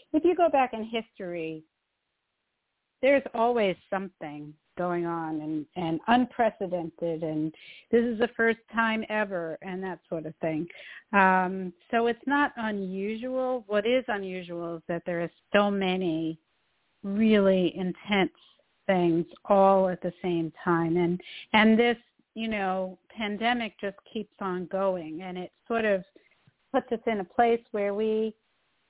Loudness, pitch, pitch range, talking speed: -28 LUFS, 195 Hz, 175-230 Hz, 145 wpm